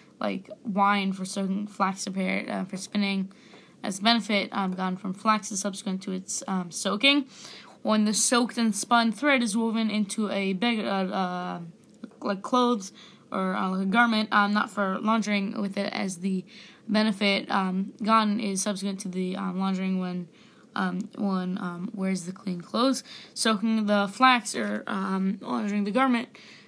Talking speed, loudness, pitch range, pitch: 170 wpm, -26 LUFS, 190-225 Hz, 200 Hz